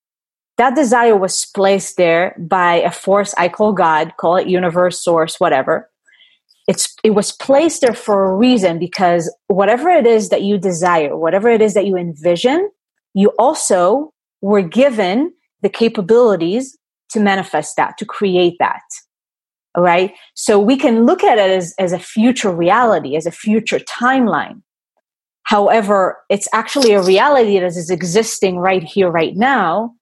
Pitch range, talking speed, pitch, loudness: 180-240 Hz, 155 wpm, 200 Hz, -14 LUFS